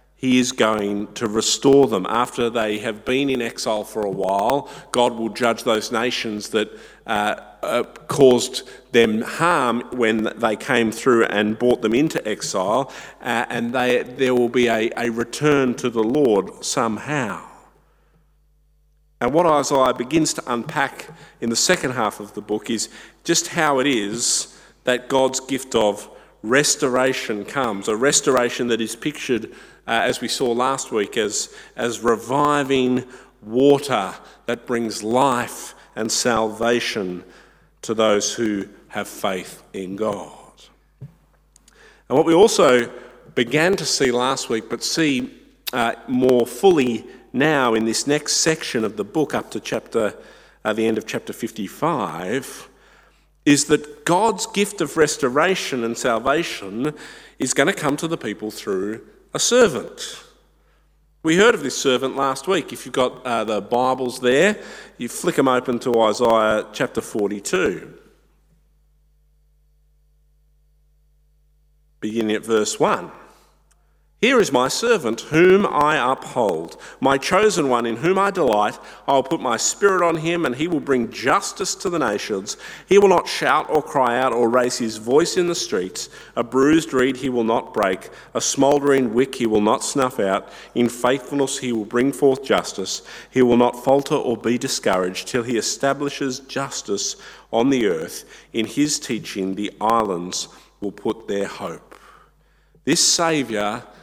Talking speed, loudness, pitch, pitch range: 150 wpm, -20 LUFS, 125 Hz, 115-150 Hz